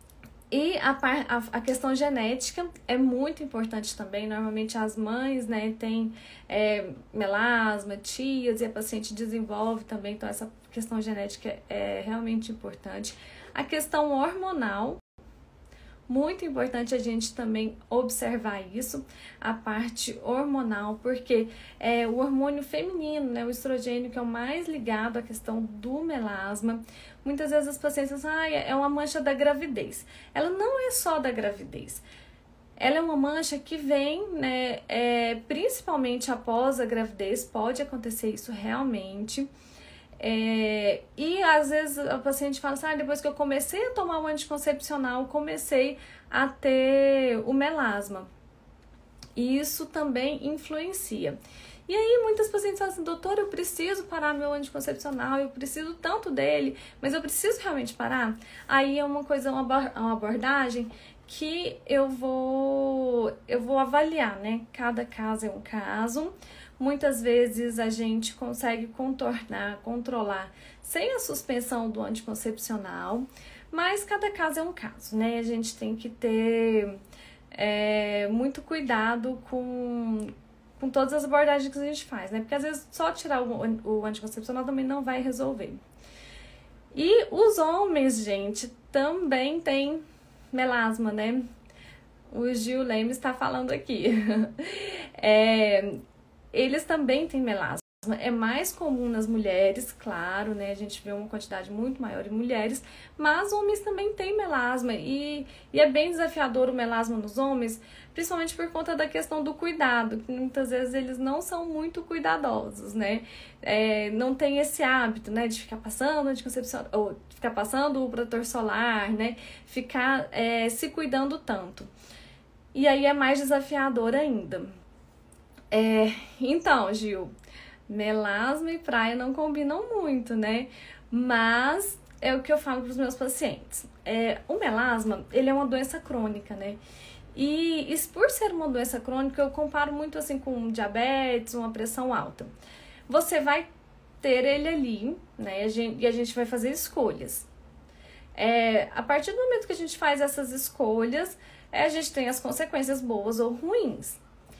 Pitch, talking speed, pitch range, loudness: 255 Hz, 150 wpm, 225-290 Hz, -28 LUFS